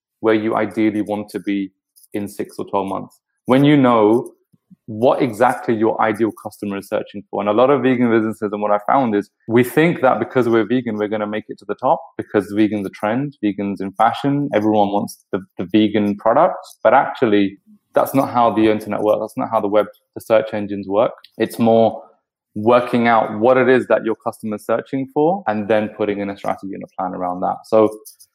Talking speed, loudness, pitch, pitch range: 220 wpm, -18 LUFS, 110 Hz, 105-115 Hz